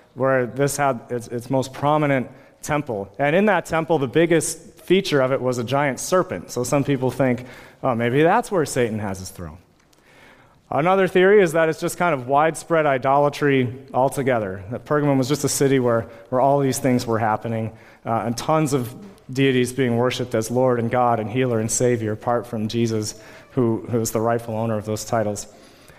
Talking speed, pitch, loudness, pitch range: 190 wpm, 130 Hz, -21 LUFS, 115-145 Hz